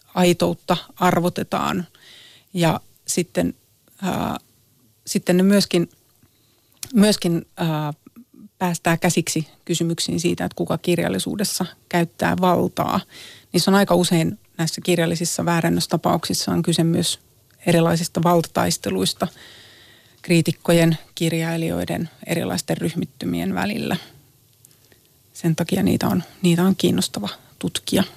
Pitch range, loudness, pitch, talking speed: 125-180 Hz, -21 LUFS, 170 Hz, 95 wpm